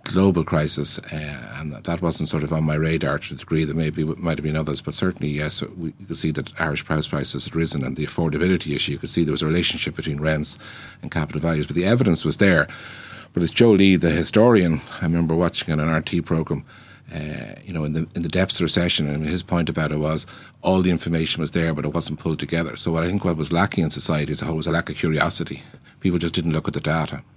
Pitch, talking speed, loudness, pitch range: 80 Hz, 255 wpm, -22 LUFS, 75-85 Hz